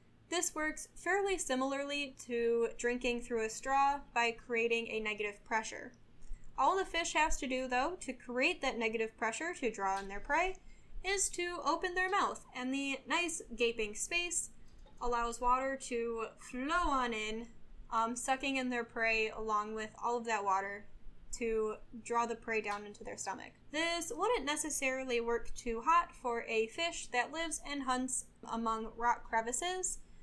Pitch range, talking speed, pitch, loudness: 225-310 Hz, 165 wpm, 245 Hz, -35 LUFS